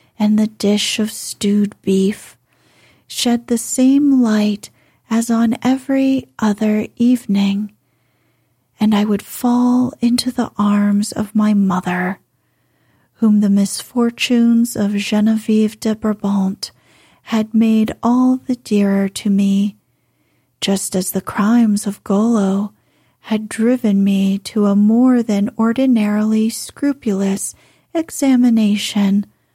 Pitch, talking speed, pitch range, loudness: 215 Hz, 110 wpm, 205-235 Hz, -16 LUFS